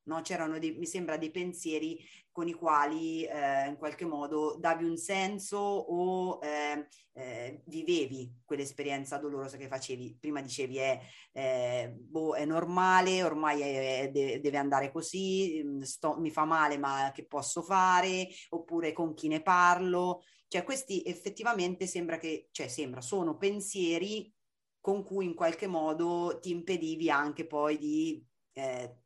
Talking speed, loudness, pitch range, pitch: 145 wpm, -33 LUFS, 145-180 Hz, 160 Hz